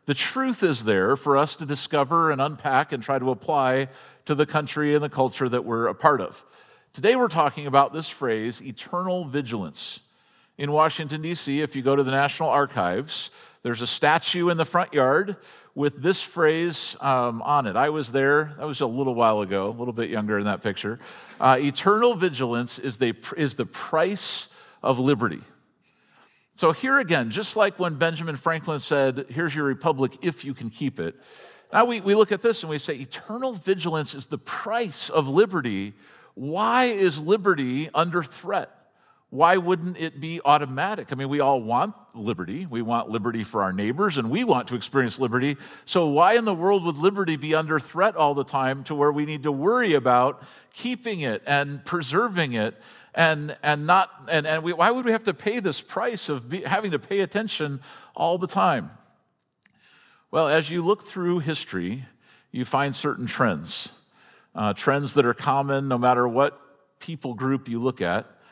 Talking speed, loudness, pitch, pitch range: 185 wpm, -24 LUFS, 150 Hz, 135-175 Hz